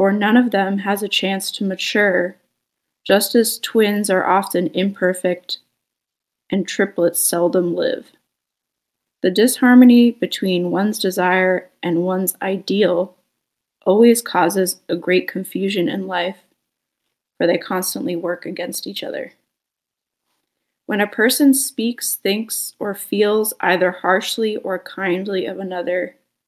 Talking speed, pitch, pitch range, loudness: 120 wpm, 190 Hz, 180-210 Hz, -18 LUFS